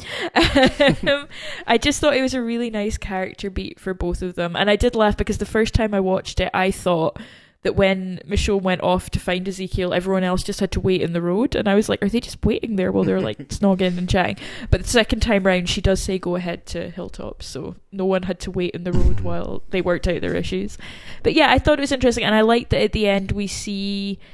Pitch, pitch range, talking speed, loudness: 195 Hz, 185-220 Hz, 250 wpm, -20 LUFS